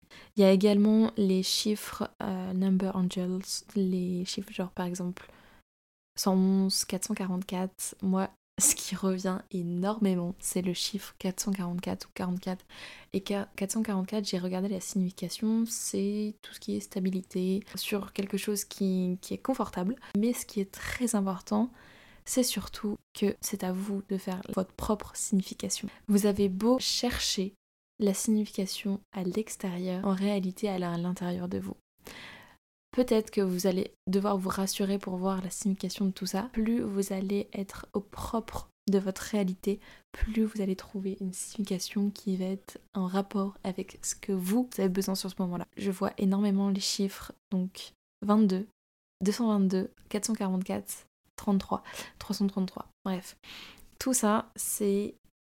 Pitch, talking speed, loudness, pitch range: 195 Hz, 150 wpm, -31 LUFS, 190-210 Hz